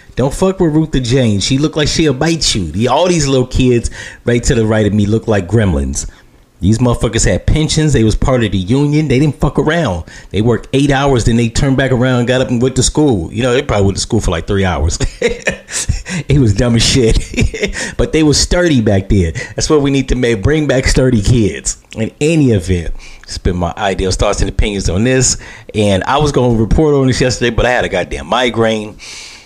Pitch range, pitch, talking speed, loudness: 105-135 Hz, 120 Hz, 230 wpm, -13 LUFS